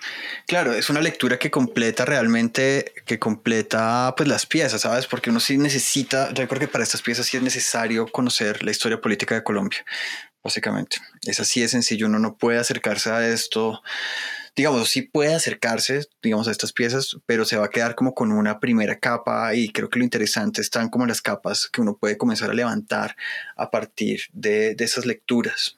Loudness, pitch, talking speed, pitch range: -22 LUFS, 125 Hz, 190 wpm, 115-150 Hz